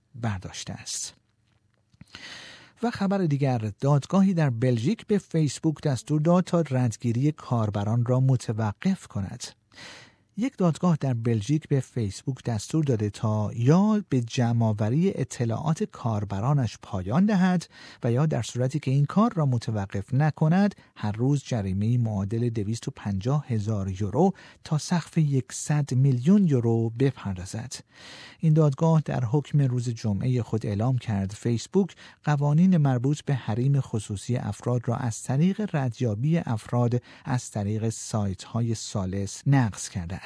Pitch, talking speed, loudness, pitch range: 125 Hz, 125 wpm, -26 LUFS, 110-150 Hz